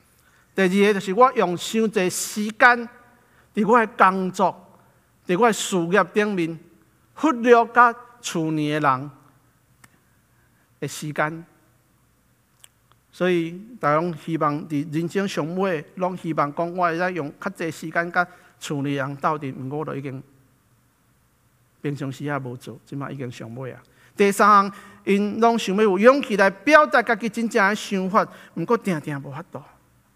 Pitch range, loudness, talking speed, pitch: 145-205 Hz, -21 LUFS, 210 characters per minute, 175 Hz